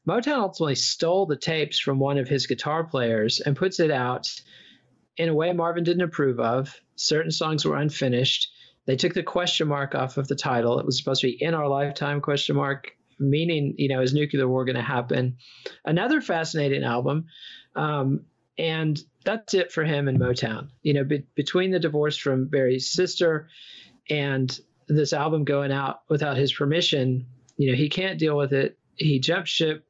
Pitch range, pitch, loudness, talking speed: 135-160 Hz, 145 Hz, -24 LUFS, 185 wpm